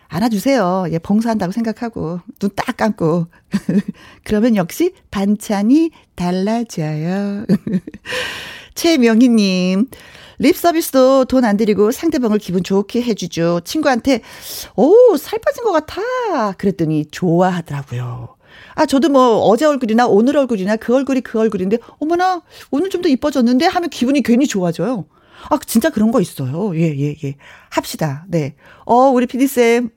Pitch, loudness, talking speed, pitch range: 225 Hz, -16 LUFS, 295 characters per minute, 185-275 Hz